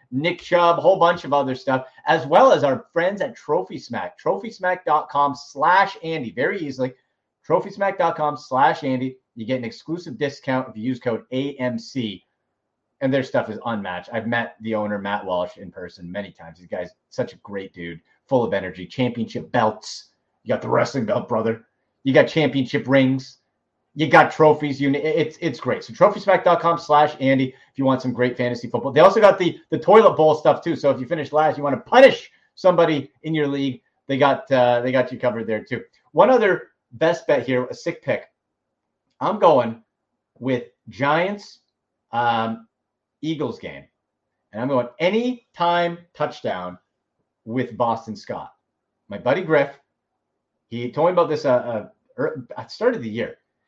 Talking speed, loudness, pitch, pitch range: 175 wpm, -20 LUFS, 135 Hz, 120-160 Hz